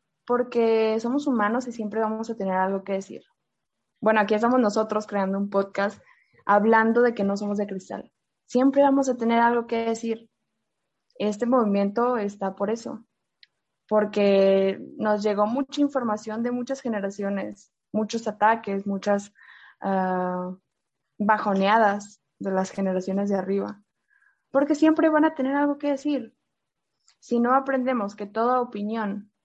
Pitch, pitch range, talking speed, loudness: 215 Hz, 200-245 Hz, 140 wpm, -24 LUFS